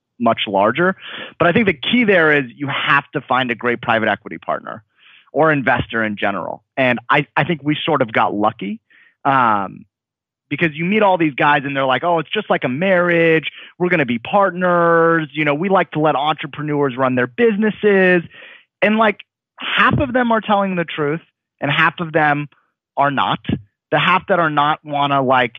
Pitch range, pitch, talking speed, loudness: 130-180 Hz, 150 Hz, 200 wpm, -16 LUFS